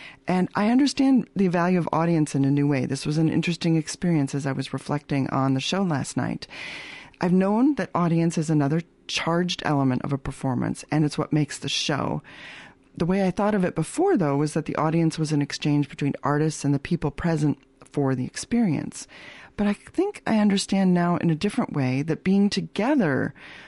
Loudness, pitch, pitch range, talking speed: -24 LUFS, 160 Hz, 145-185 Hz, 200 wpm